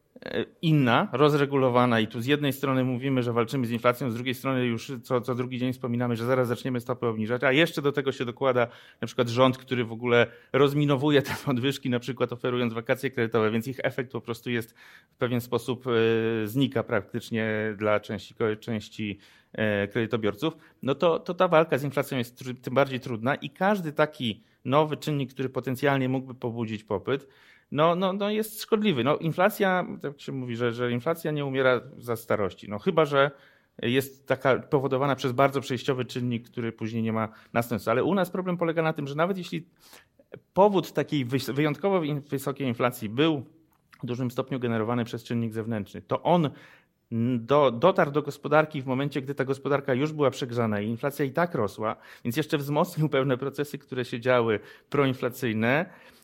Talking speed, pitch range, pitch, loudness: 180 wpm, 120-145 Hz, 130 Hz, -27 LUFS